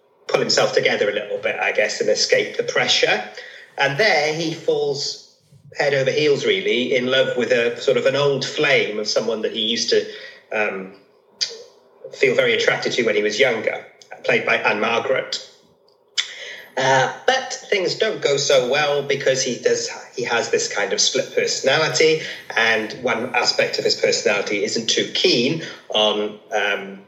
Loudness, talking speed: -19 LUFS, 165 wpm